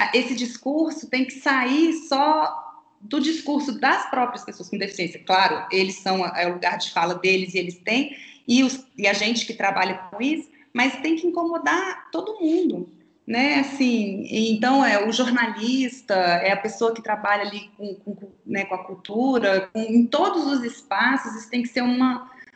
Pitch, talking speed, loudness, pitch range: 240 Hz, 185 wpm, -22 LUFS, 200-275 Hz